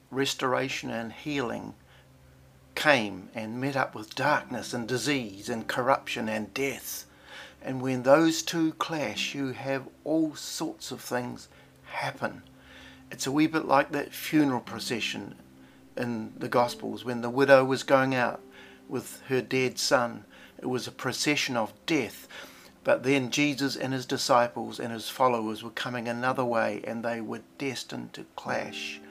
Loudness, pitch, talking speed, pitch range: -28 LUFS, 125 Hz, 150 wpm, 110-135 Hz